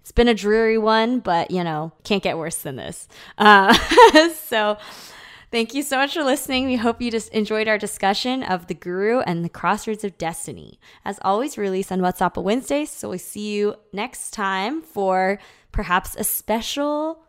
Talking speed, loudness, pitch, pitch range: 185 wpm, -20 LUFS, 215 Hz, 190-250 Hz